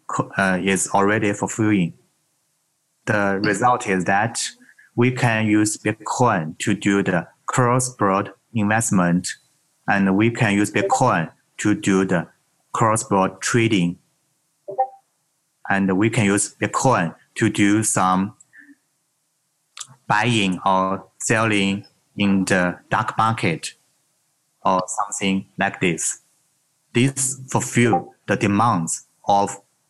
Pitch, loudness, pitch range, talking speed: 105 Hz, -20 LUFS, 100-130 Hz, 100 wpm